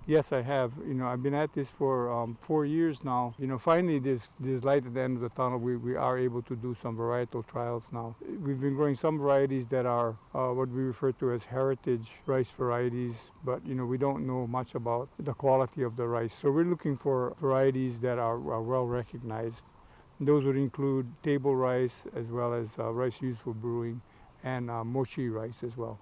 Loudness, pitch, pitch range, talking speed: -31 LUFS, 125 Hz, 120-135 Hz, 220 wpm